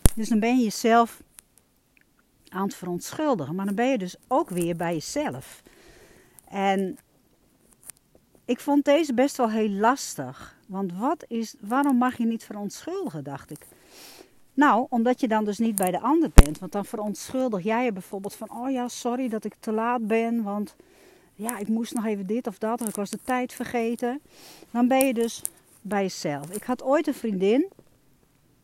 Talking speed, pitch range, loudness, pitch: 180 wpm, 205-255 Hz, -26 LUFS, 230 Hz